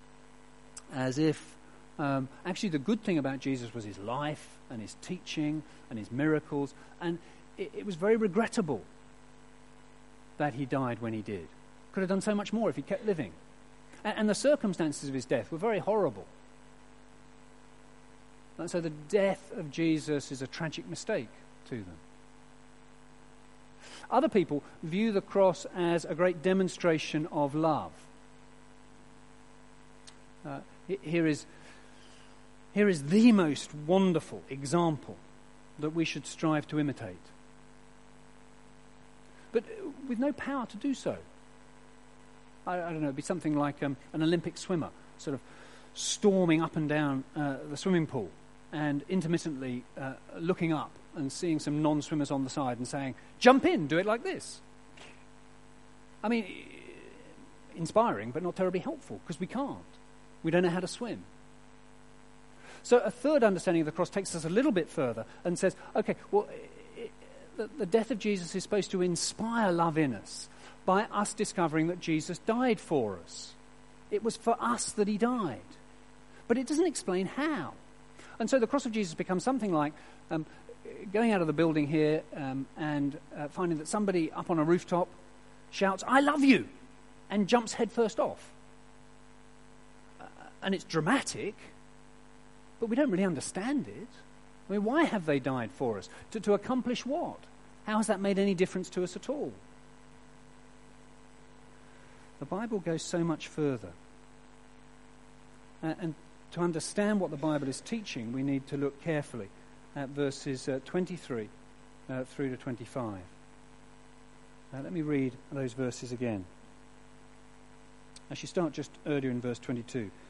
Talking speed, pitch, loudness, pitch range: 155 wpm, 170 Hz, -32 LUFS, 140-210 Hz